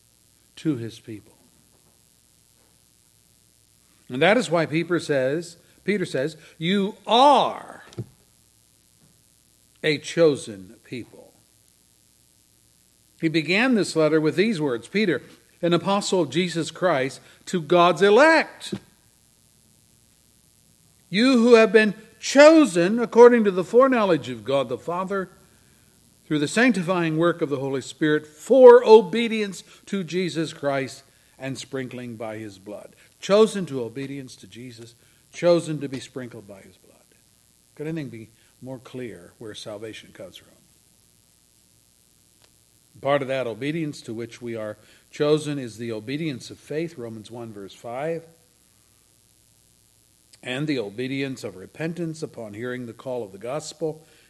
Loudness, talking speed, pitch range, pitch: -21 LUFS, 125 wpm, 120-175 Hz, 150 Hz